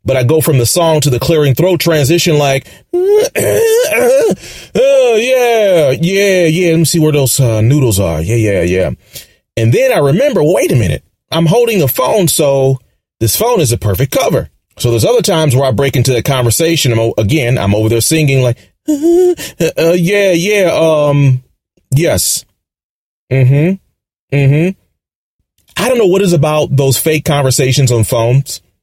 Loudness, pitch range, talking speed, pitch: -11 LUFS, 125-175 Hz, 175 wpm, 145 Hz